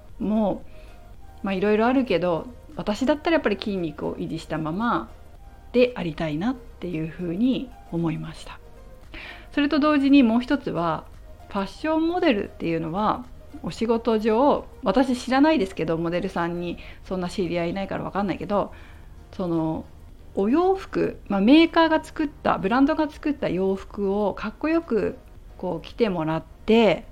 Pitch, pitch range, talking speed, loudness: 205 Hz, 170-265 Hz, 330 characters per minute, -24 LUFS